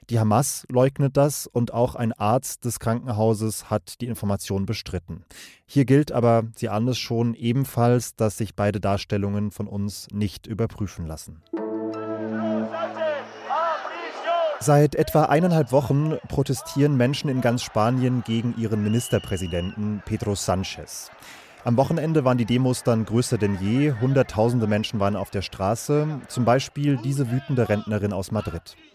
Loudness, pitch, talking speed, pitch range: -23 LUFS, 115 Hz, 135 wpm, 105-130 Hz